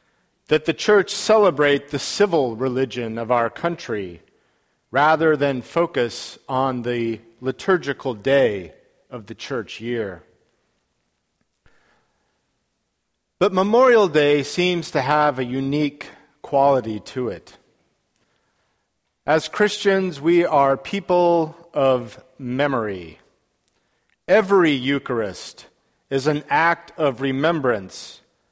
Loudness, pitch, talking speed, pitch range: -20 LUFS, 145 Hz, 95 wpm, 130-170 Hz